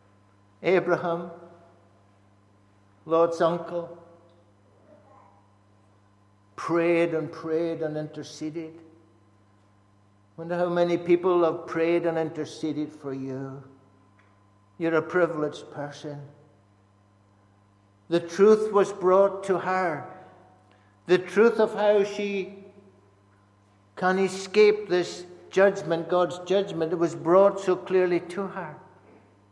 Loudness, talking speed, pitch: -25 LUFS, 95 wpm, 160 Hz